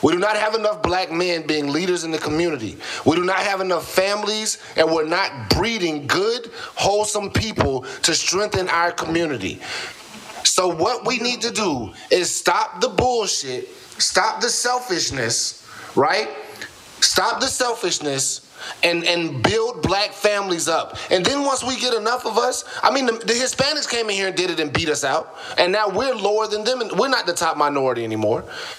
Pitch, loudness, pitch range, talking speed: 200 Hz, -20 LUFS, 165-240 Hz, 185 wpm